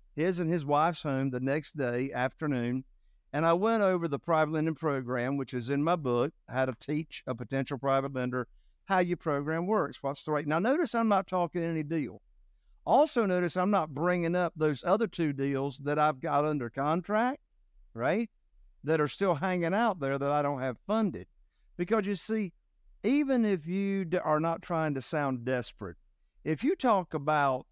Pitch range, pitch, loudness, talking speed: 135-185 Hz, 155 Hz, -30 LUFS, 185 wpm